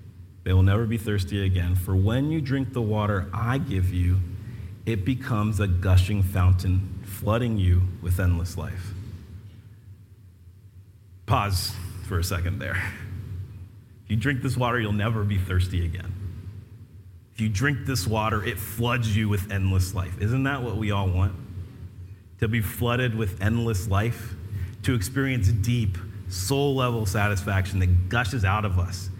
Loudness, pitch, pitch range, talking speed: -25 LUFS, 100 Hz, 95-110 Hz, 150 wpm